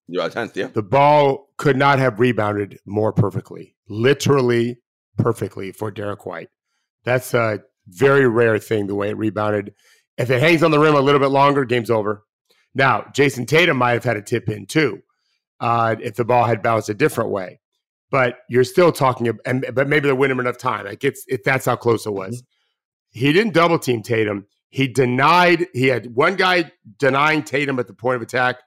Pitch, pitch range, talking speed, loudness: 125 Hz, 110-140 Hz, 190 wpm, -18 LUFS